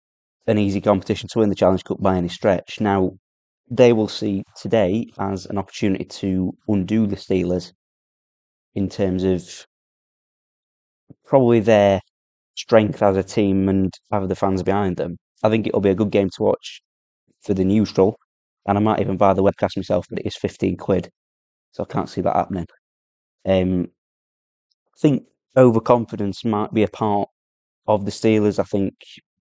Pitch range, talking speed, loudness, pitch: 95-105 Hz, 165 wpm, -20 LUFS, 100 Hz